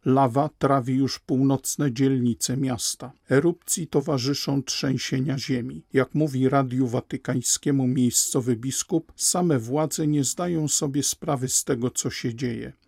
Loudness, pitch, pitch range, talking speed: -24 LUFS, 135 Hz, 130-145 Hz, 125 wpm